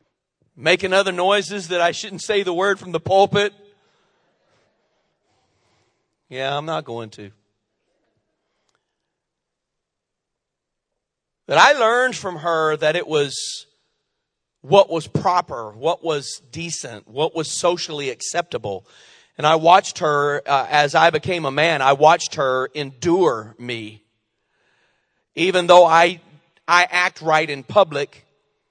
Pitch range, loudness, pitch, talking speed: 140-180 Hz, -18 LUFS, 160 Hz, 120 wpm